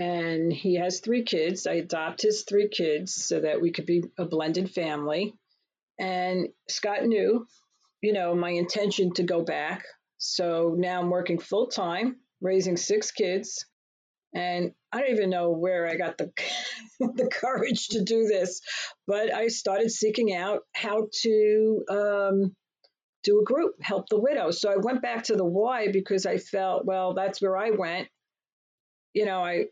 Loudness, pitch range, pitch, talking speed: -27 LUFS, 175-215 Hz, 190 Hz, 170 wpm